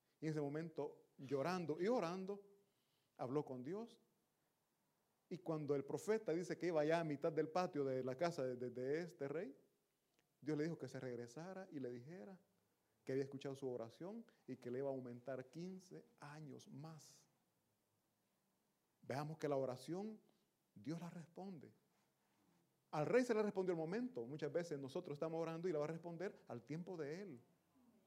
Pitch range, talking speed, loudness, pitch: 135-180 Hz, 175 wpm, -46 LUFS, 155 Hz